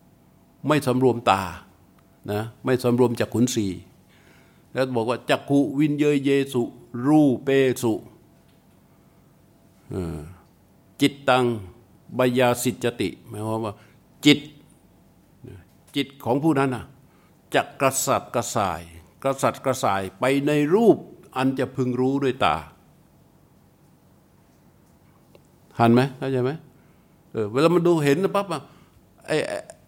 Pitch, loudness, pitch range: 125 Hz, -23 LUFS, 110-140 Hz